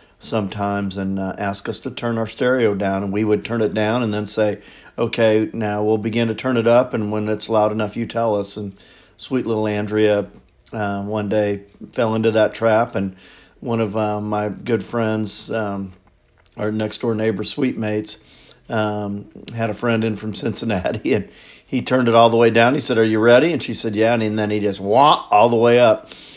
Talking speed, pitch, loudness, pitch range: 210 wpm, 110 Hz, -19 LUFS, 105-115 Hz